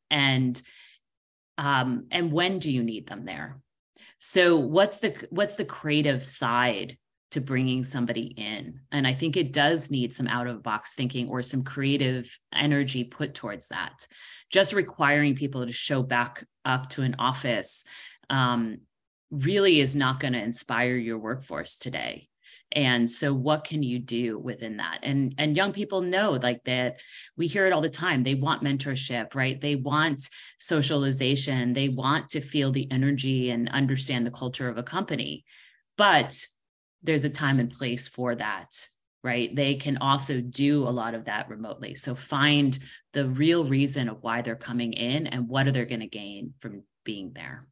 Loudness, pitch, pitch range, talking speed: -26 LUFS, 135 Hz, 125-145 Hz, 170 wpm